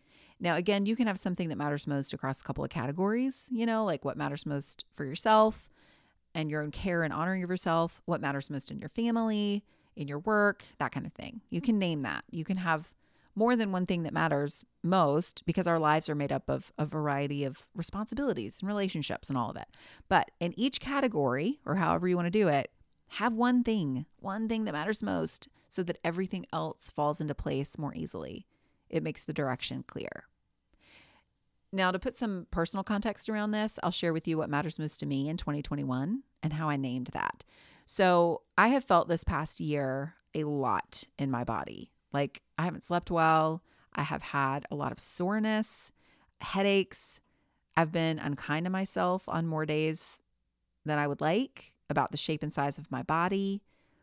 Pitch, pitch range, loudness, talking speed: 170 Hz, 145-200 Hz, -31 LUFS, 195 wpm